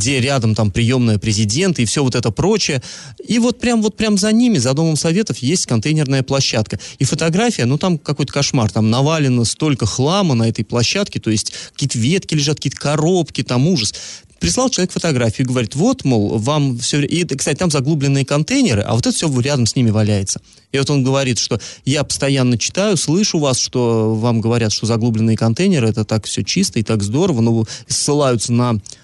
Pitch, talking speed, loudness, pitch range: 135 Hz, 190 wpm, -16 LUFS, 115-160 Hz